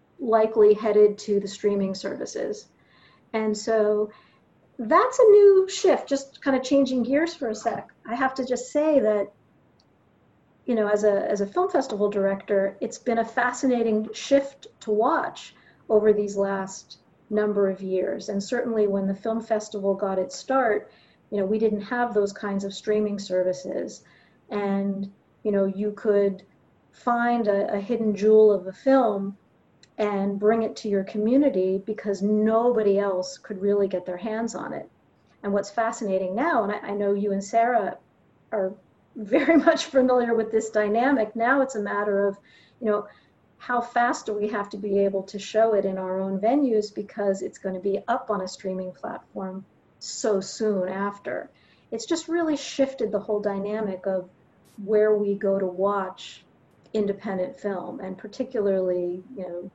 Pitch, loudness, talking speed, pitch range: 210 Hz, -24 LUFS, 170 wpm, 195-235 Hz